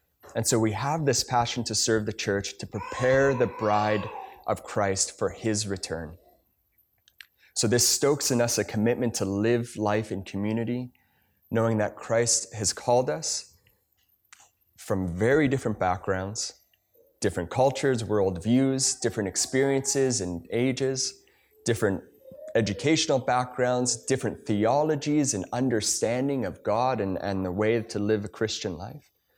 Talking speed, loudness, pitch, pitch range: 135 wpm, -26 LUFS, 115 Hz, 105-130 Hz